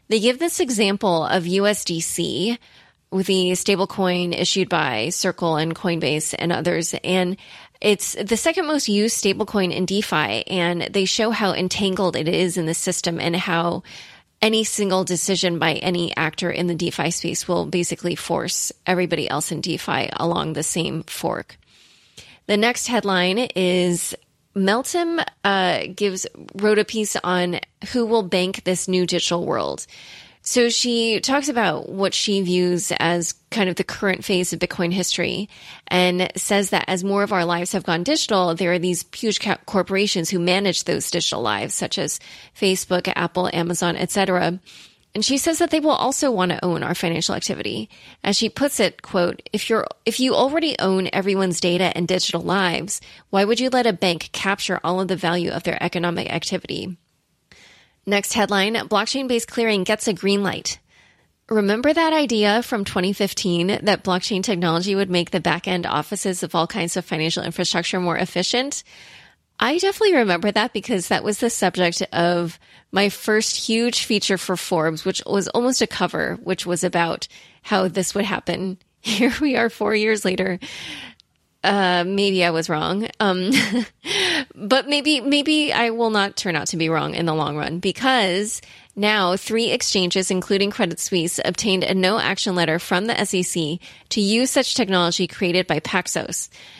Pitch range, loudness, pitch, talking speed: 175-215 Hz, -21 LUFS, 190 Hz, 165 wpm